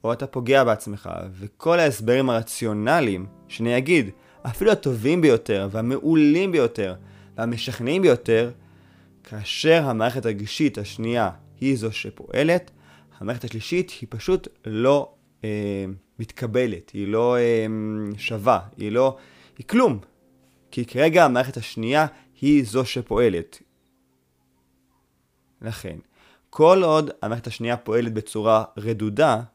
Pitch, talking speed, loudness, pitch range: 115 Hz, 110 wpm, -22 LUFS, 100-130 Hz